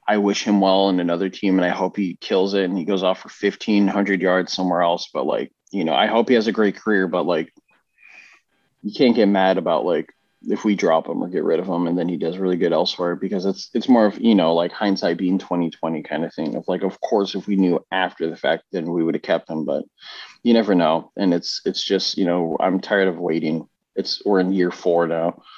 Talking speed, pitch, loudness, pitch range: 250 wpm, 95 Hz, -20 LUFS, 85-100 Hz